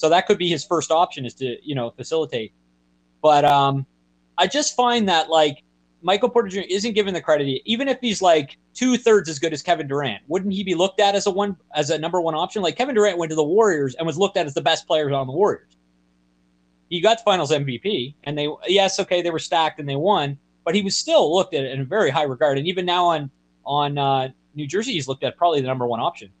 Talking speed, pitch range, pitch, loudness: 250 wpm, 135-195 Hz, 160 Hz, -21 LUFS